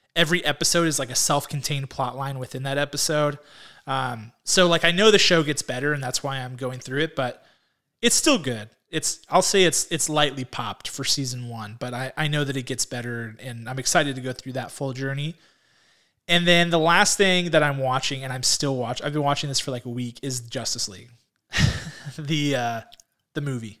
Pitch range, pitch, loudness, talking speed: 125-155 Hz, 135 Hz, -23 LUFS, 215 wpm